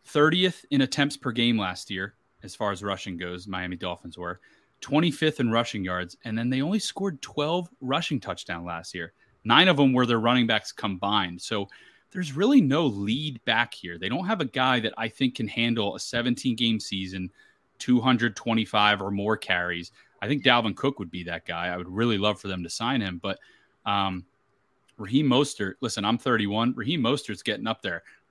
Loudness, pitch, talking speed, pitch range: -26 LUFS, 115 Hz, 195 wpm, 95-130 Hz